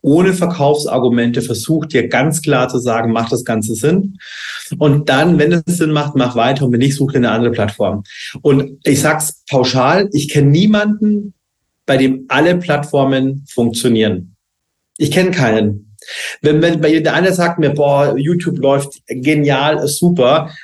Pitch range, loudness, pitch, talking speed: 125-160 Hz, -14 LUFS, 145 Hz, 155 wpm